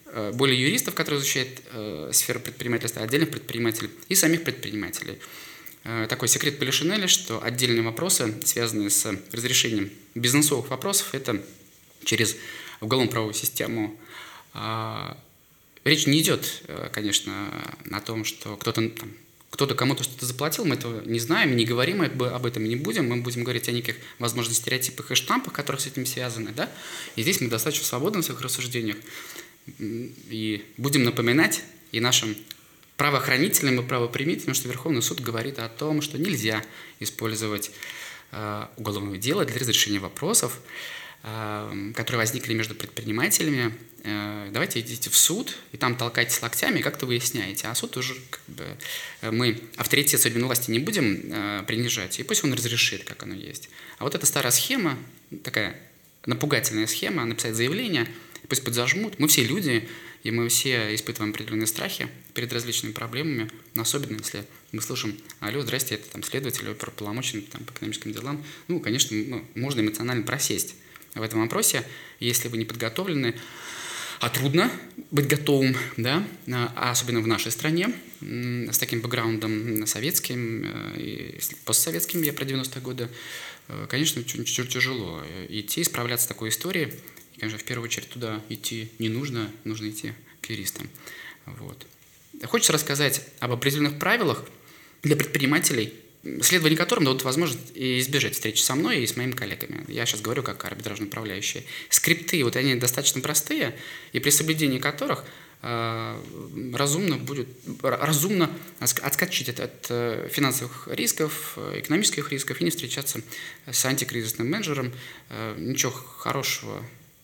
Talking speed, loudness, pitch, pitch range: 145 wpm, -25 LUFS, 120 Hz, 110-145 Hz